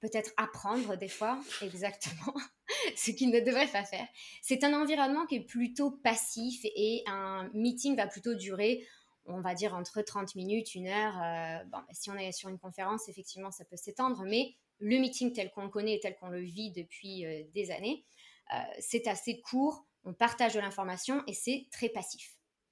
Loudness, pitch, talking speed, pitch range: -34 LUFS, 215 Hz, 180 wpm, 195-245 Hz